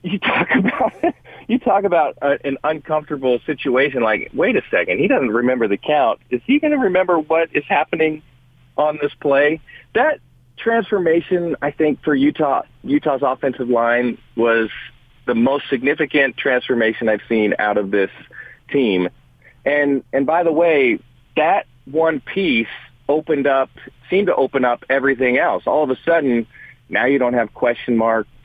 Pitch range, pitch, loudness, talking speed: 125-160 Hz, 140 Hz, -18 LUFS, 160 wpm